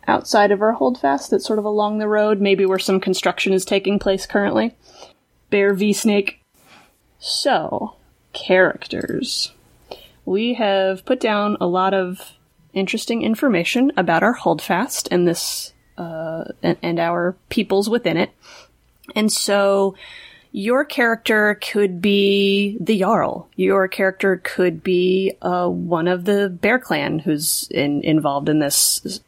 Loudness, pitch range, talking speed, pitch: -19 LUFS, 180-215 Hz, 135 wpm, 195 Hz